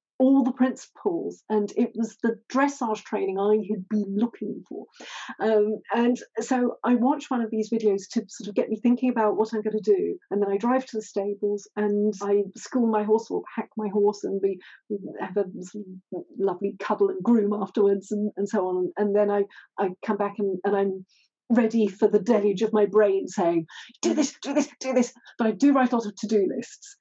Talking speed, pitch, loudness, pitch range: 215 wpm, 215 Hz, -25 LUFS, 205-245 Hz